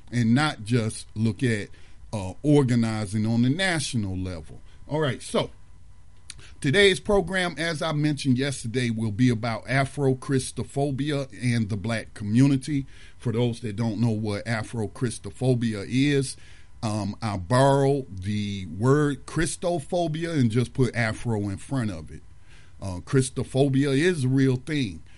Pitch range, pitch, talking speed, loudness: 105-140 Hz, 120 Hz, 135 wpm, -25 LUFS